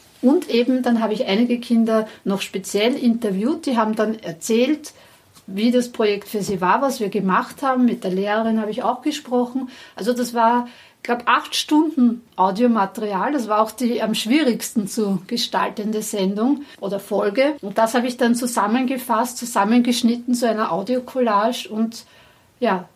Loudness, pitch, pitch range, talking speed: -20 LUFS, 230 Hz, 210-250 Hz, 165 wpm